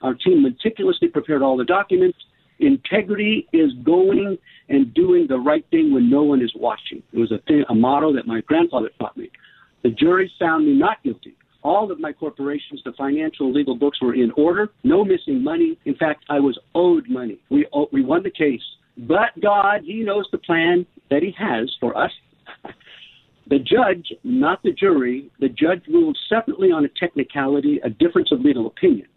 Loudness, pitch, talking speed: -19 LUFS, 205 Hz, 185 wpm